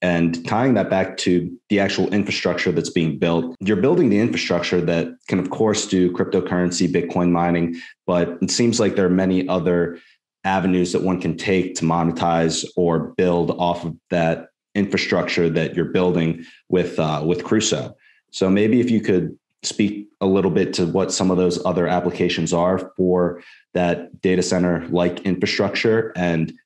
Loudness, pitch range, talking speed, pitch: -20 LUFS, 85-95 Hz, 170 wpm, 90 Hz